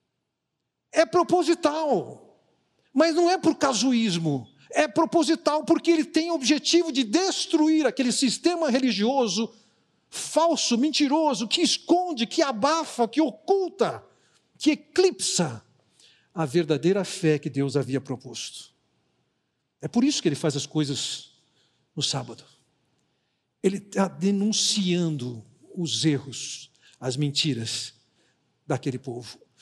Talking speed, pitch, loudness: 110 wpm, 210 Hz, -24 LUFS